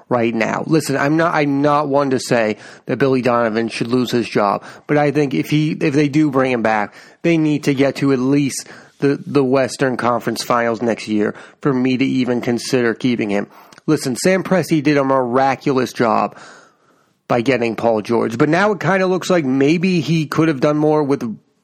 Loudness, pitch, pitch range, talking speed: -17 LUFS, 135 Hz, 120-150 Hz, 205 wpm